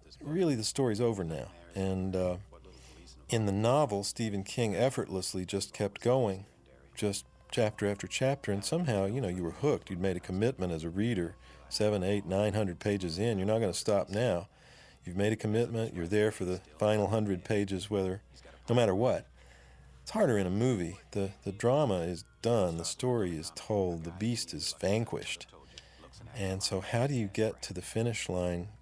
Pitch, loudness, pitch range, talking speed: 100 Hz, -32 LUFS, 90-110 Hz, 185 wpm